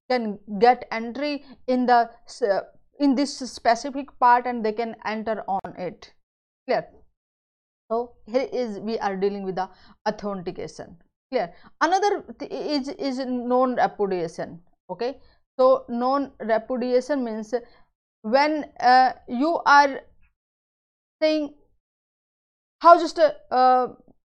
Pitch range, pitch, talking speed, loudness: 220-275 Hz, 245 Hz, 120 wpm, -23 LUFS